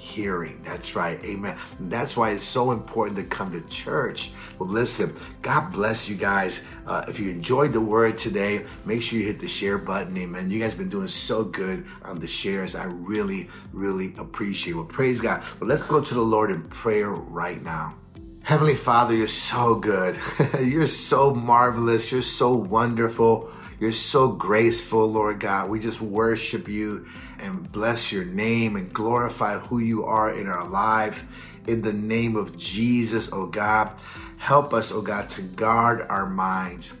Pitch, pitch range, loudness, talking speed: 110 Hz, 100-115 Hz, -23 LUFS, 180 wpm